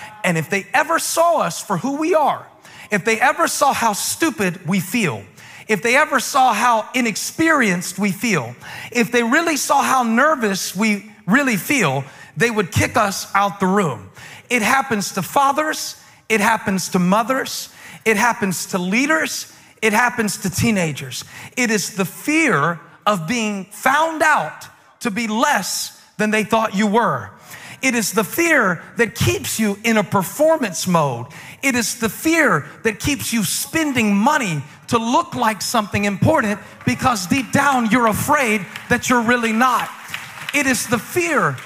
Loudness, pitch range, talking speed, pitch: -18 LUFS, 195-260 Hz, 160 wpm, 225 Hz